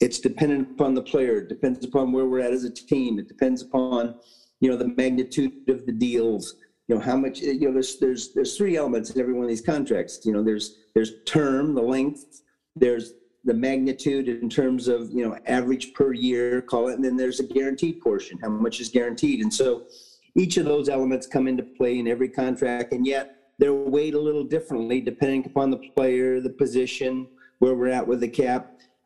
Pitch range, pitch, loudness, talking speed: 125-135 Hz, 130 Hz, -24 LUFS, 210 wpm